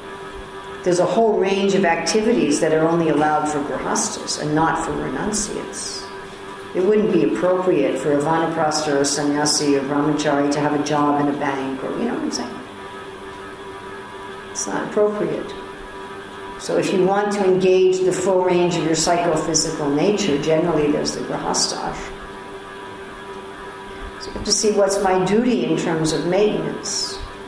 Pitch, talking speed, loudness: 150 Hz, 160 wpm, -19 LUFS